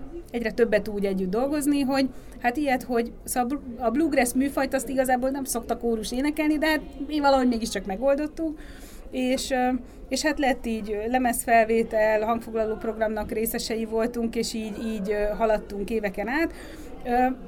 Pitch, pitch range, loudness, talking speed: 240 Hz, 225-270 Hz, -25 LUFS, 135 wpm